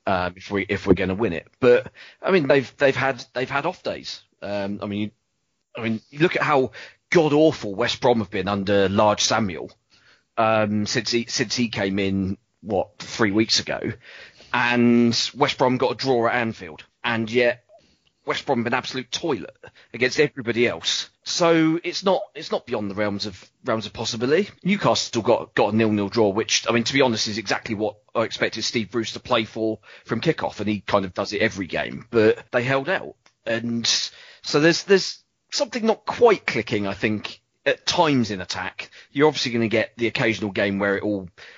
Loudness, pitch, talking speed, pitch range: -22 LUFS, 115 Hz, 205 wpm, 105-130 Hz